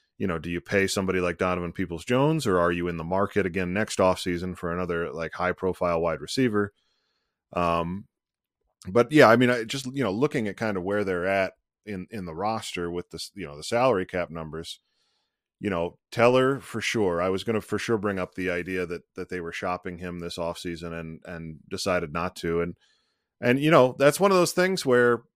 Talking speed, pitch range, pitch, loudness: 215 wpm, 85-115 Hz, 95 Hz, -25 LUFS